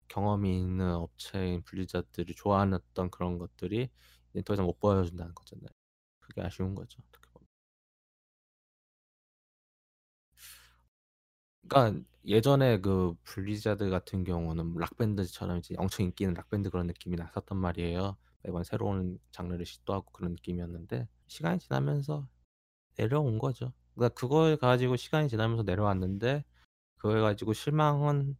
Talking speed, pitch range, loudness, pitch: 325 characters per minute, 85-105 Hz, -32 LUFS, 95 Hz